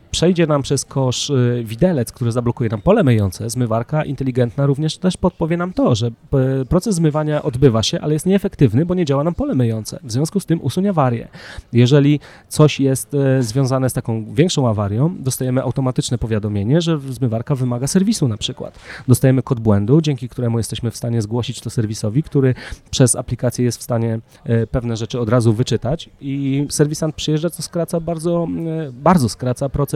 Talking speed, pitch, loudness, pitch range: 170 wpm, 135 Hz, -18 LUFS, 120-155 Hz